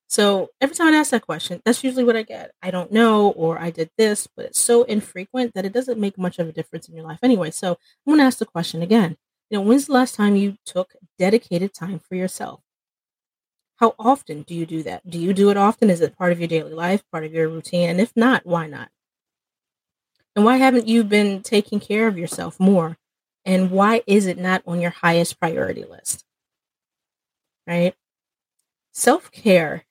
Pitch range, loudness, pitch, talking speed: 170-230 Hz, -20 LUFS, 195 Hz, 205 wpm